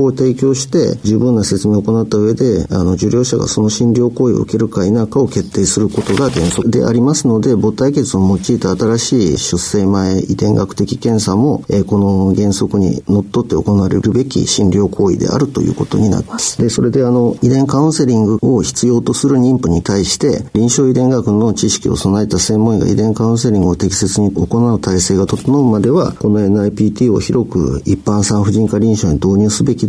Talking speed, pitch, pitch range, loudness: 390 characters per minute, 110 Hz, 100-120 Hz, -13 LUFS